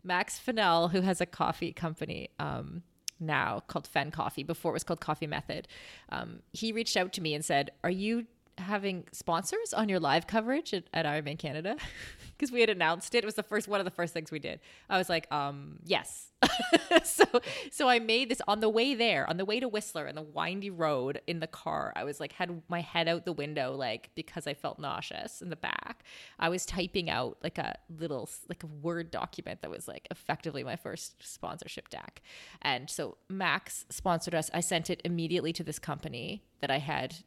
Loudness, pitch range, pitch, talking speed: -32 LUFS, 160-210 Hz, 175 Hz, 210 wpm